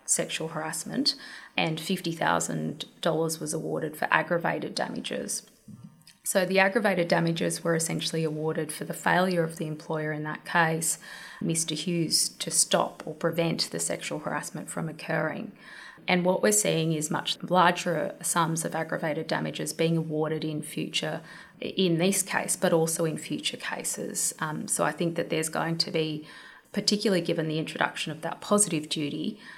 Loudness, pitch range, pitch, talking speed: -27 LUFS, 155-180 Hz, 165 Hz, 155 wpm